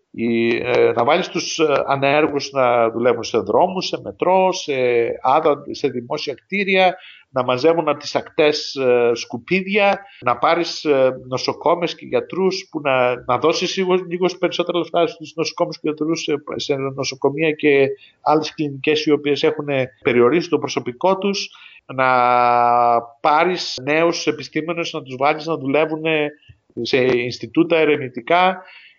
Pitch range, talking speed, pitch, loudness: 130-170 Hz, 135 wpm, 150 Hz, -18 LUFS